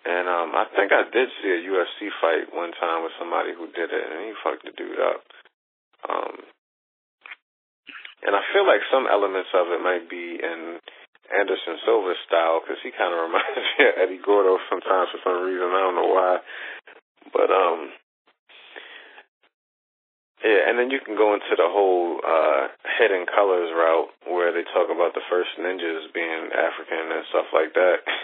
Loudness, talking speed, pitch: -22 LUFS, 180 wpm, 100 Hz